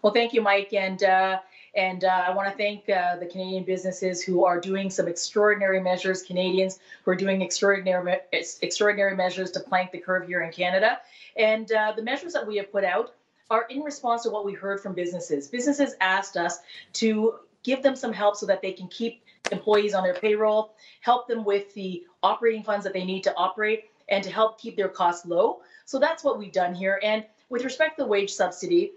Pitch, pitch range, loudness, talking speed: 195 Hz, 185-220 Hz, -25 LUFS, 215 wpm